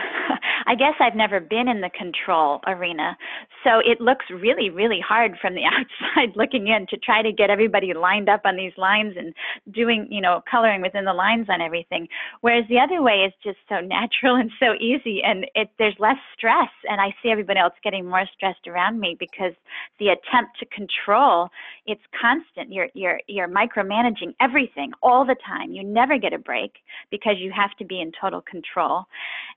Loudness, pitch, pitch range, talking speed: -21 LUFS, 210 Hz, 190-235 Hz, 190 wpm